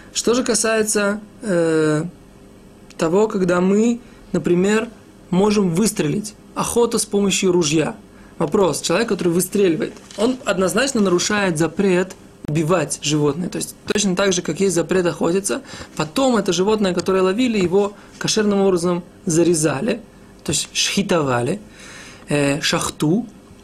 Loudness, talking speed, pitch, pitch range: -19 LUFS, 120 wpm, 190 Hz, 175-210 Hz